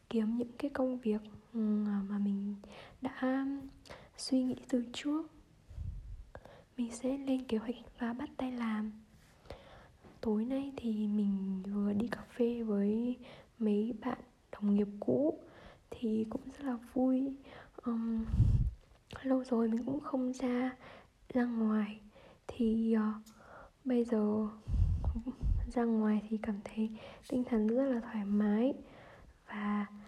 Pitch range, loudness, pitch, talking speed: 215-255 Hz, -35 LUFS, 230 Hz, 125 wpm